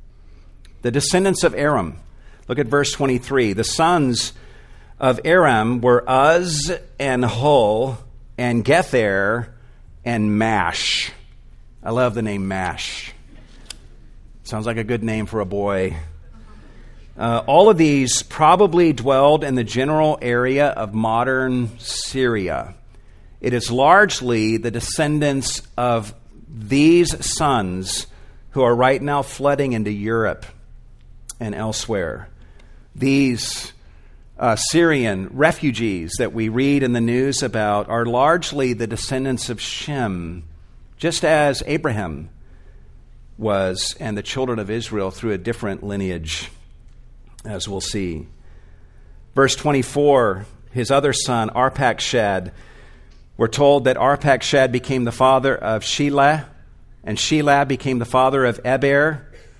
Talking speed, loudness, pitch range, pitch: 120 wpm, -19 LUFS, 105-135 Hz, 120 Hz